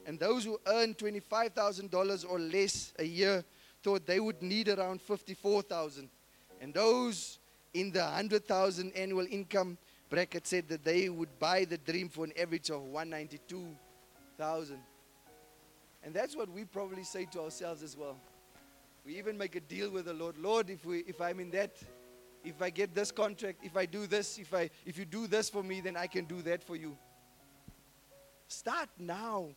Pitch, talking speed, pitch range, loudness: 180 Hz, 175 wpm, 160-200 Hz, -36 LUFS